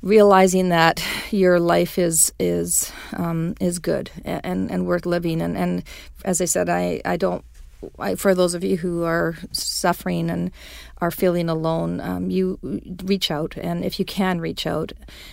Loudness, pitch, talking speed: -21 LUFS, 170 Hz, 170 wpm